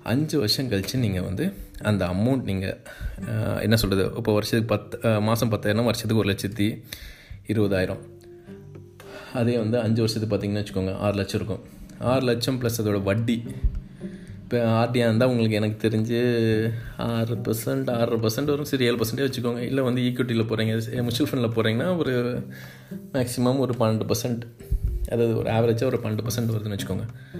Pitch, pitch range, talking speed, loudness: 115 Hz, 105-120 Hz, 145 wpm, -25 LUFS